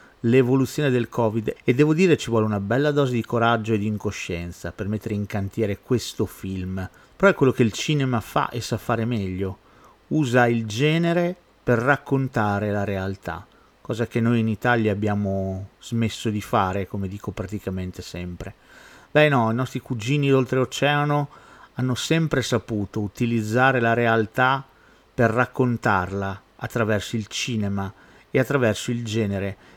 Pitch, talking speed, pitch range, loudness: 115 Hz, 150 wpm, 100-130 Hz, -23 LUFS